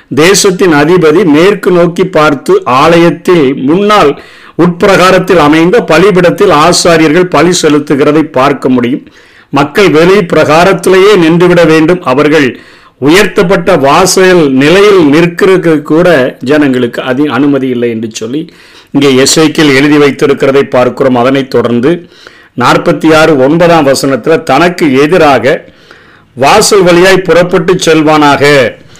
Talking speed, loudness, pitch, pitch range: 100 wpm, -5 LUFS, 160 Hz, 145-180 Hz